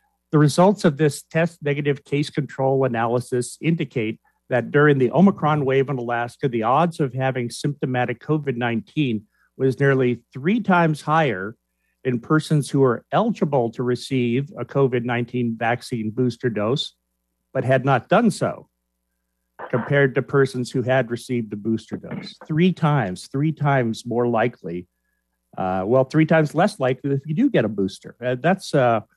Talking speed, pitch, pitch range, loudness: 155 wpm, 130 Hz, 120-150 Hz, -21 LUFS